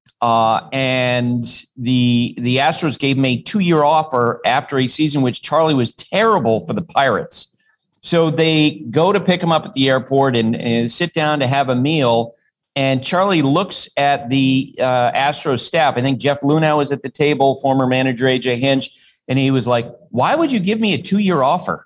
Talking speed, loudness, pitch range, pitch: 190 wpm, -16 LUFS, 125-155 Hz, 135 Hz